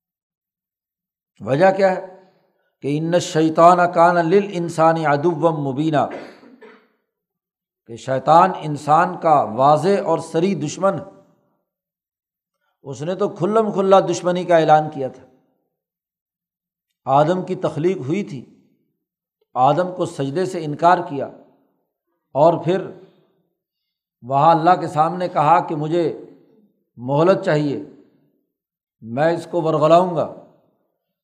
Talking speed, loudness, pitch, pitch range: 110 wpm, -18 LUFS, 175 Hz, 155-185 Hz